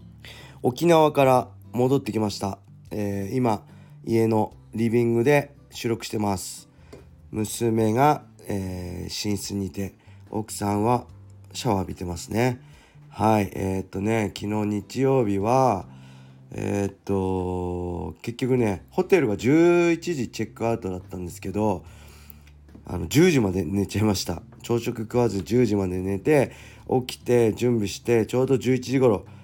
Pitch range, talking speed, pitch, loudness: 95-120 Hz, 255 characters per minute, 105 Hz, -24 LUFS